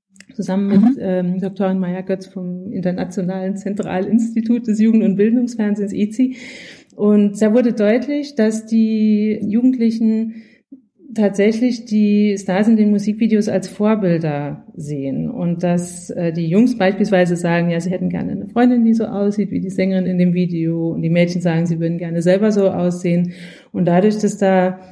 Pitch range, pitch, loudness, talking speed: 180-220 Hz, 200 Hz, -17 LUFS, 160 wpm